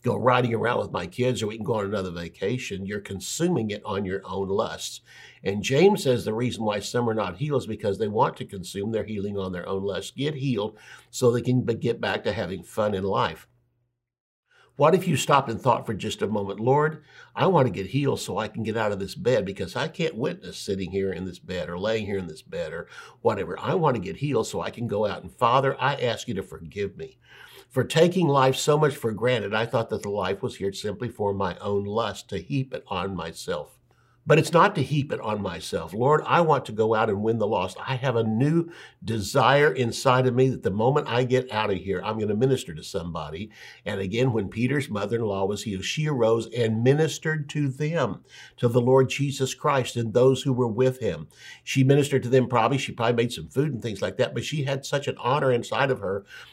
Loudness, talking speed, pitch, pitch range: -25 LUFS, 240 wpm, 120 Hz, 105-135 Hz